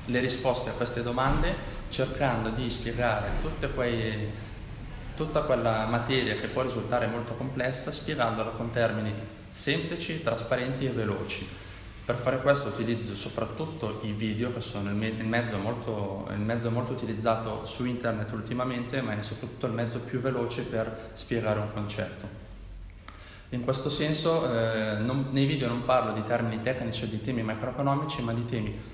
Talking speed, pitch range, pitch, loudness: 155 wpm, 110-125 Hz, 115 Hz, -30 LUFS